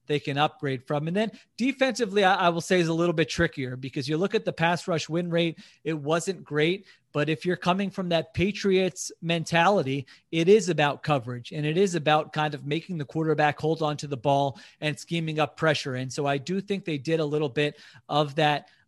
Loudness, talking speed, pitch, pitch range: -26 LUFS, 225 wpm, 160 Hz, 150-180 Hz